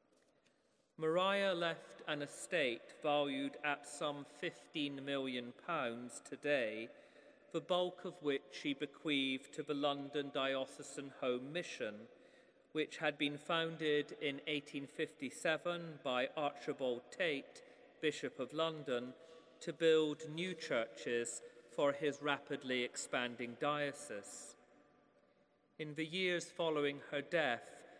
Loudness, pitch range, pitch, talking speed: -40 LUFS, 140-160 Hz, 145 Hz, 105 wpm